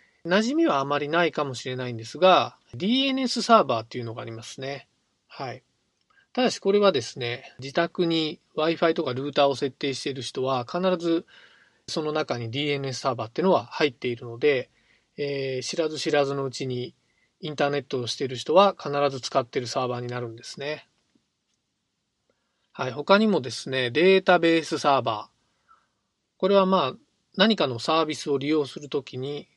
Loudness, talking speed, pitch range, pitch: -25 LUFS, 360 characters per minute, 130-170 Hz, 145 Hz